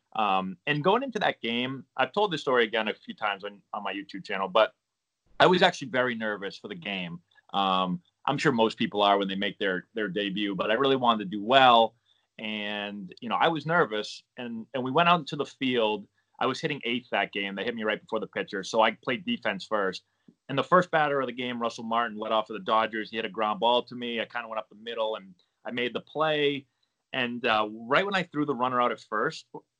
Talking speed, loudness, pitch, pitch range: 250 wpm, -27 LUFS, 115 Hz, 105-135 Hz